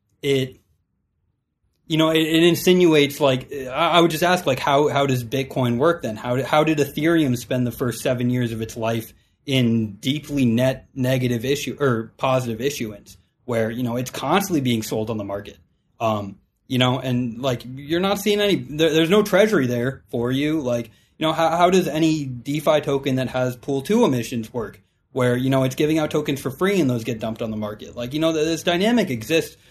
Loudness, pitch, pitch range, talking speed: -21 LUFS, 130 Hz, 120-155 Hz, 210 wpm